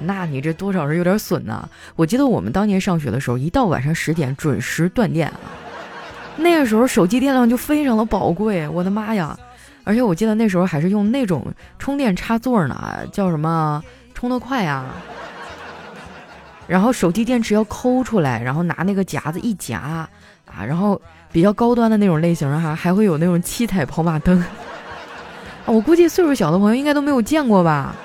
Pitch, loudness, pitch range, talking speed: 190 Hz, -18 LUFS, 165-235 Hz, 290 characters per minute